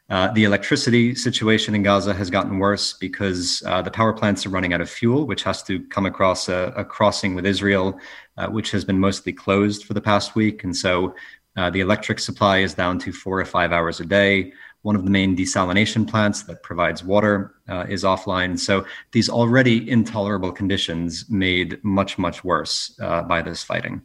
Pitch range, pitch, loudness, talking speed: 90-105 Hz, 100 Hz, -20 LUFS, 195 wpm